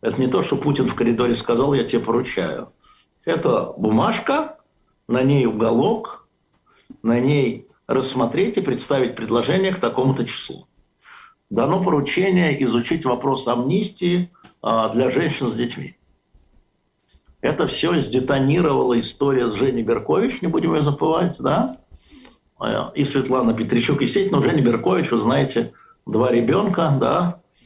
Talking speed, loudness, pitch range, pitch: 125 wpm, -20 LUFS, 120-165 Hz, 130 Hz